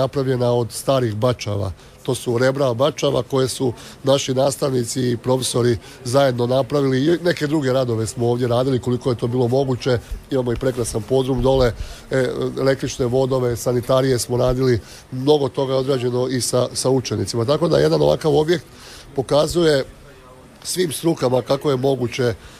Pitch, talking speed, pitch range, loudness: 130 Hz, 150 wpm, 120-135 Hz, -19 LUFS